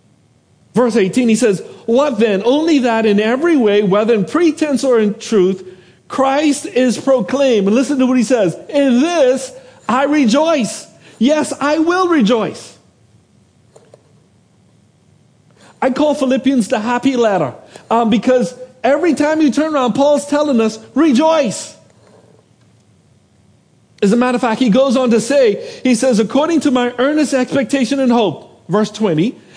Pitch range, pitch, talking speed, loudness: 220-280 Hz, 255 Hz, 145 wpm, -14 LUFS